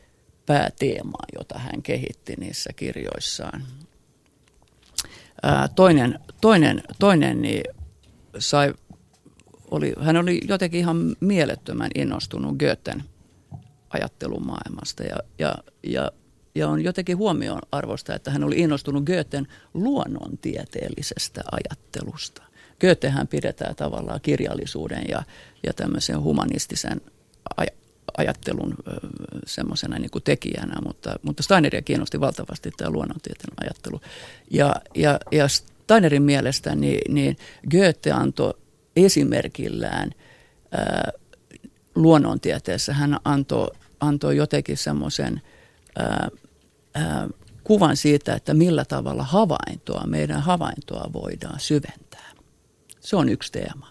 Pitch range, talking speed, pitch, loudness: 130-165 Hz, 100 wpm, 145 Hz, -23 LUFS